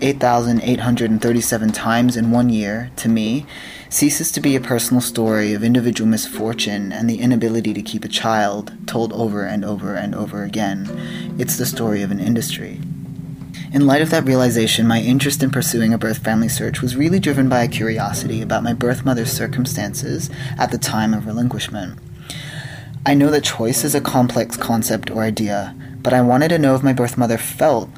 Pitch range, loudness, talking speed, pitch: 115-135 Hz, -18 LUFS, 180 wpm, 120 Hz